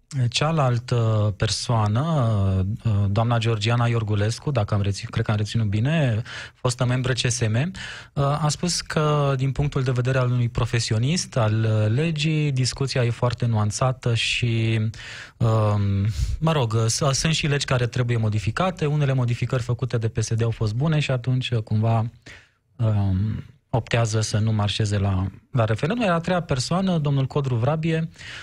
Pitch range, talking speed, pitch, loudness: 110-135 Hz, 140 wpm, 120 Hz, -23 LUFS